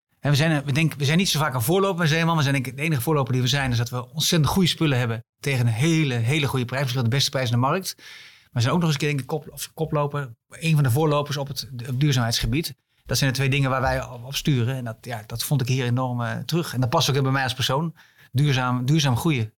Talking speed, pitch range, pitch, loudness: 290 wpm, 125-155 Hz, 135 Hz, -23 LUFS